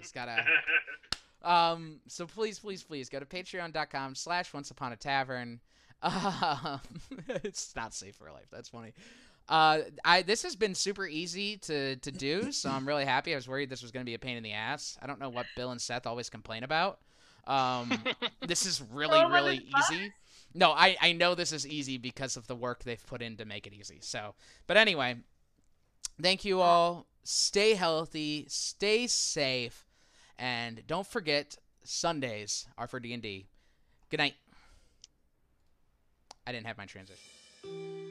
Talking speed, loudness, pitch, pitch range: 170 wpm, -31 LUFS, 140 Hz, 120-175 Hz